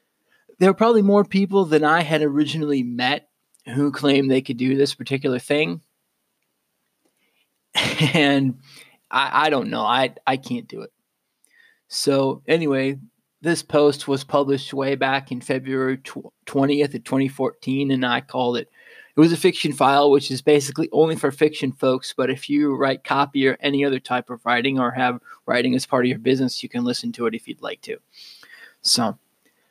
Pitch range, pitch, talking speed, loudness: 130-150 Hz, 140 Hz, 175 wpm, -20 LUFS